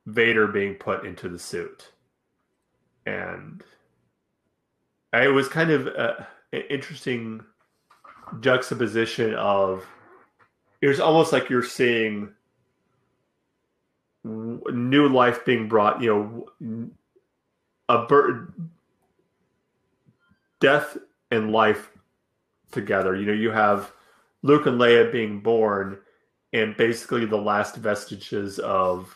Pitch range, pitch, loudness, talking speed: 105-125 Hz, 115 Hz, -22 LUFS, 100 wpm